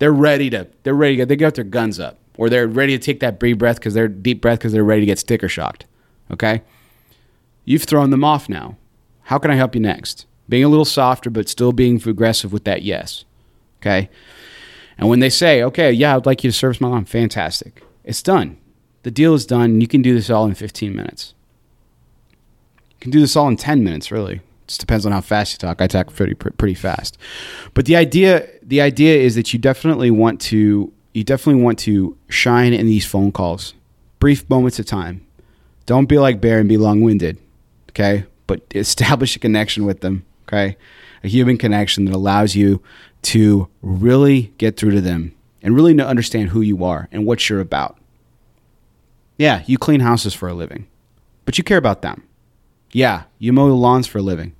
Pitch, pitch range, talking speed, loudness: 115 Hz, 100-130 Hz, 205 wpm, -16 LUFS